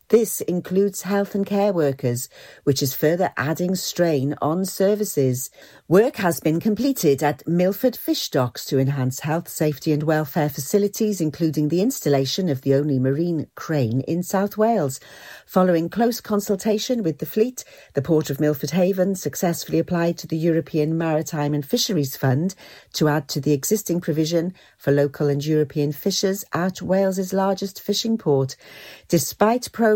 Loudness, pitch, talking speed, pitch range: -22 LUFS, 165 Hz, 155 wpm, 145-195 Hz